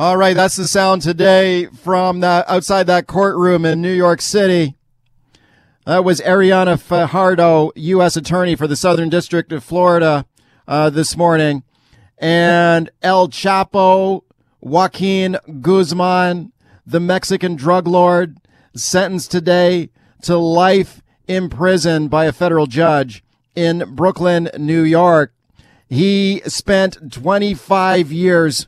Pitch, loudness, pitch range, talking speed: 175 Hz, -14 LUFS, 160-185 Hz, 120 wpm